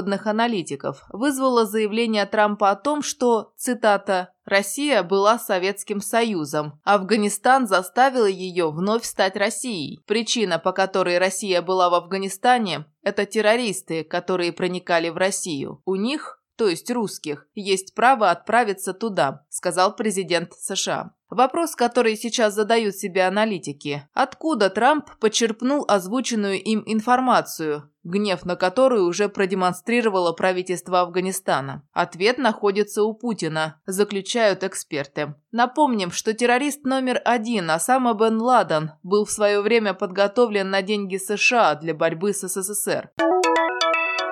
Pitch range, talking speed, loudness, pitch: 185-230 Hz, 120 wpm, -21 LUFS, 205 Hz